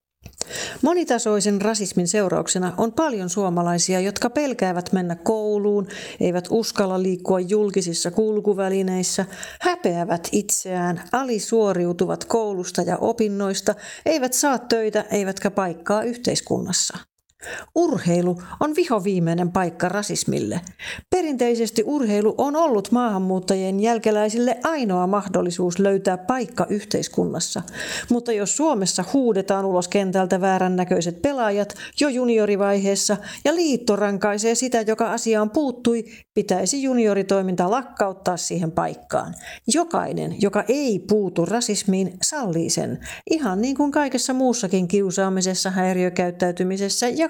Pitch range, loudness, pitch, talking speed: 185-235 Hz, -22 LUFS, 205 Hz, 105 wpm